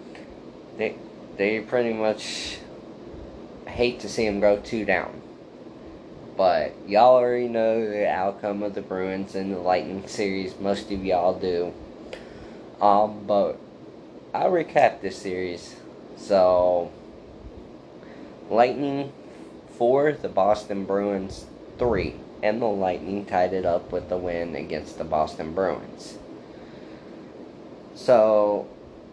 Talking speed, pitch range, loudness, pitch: 115 wpm, 95-105 Hz, -24 LUFS, 100 Hz